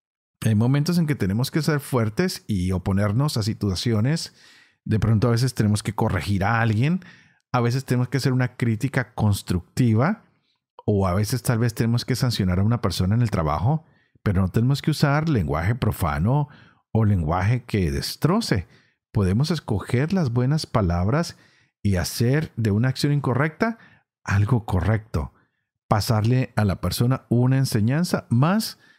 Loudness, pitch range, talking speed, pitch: -23 LUFS, 105-135 Hz, 155 wpm, 120 Hz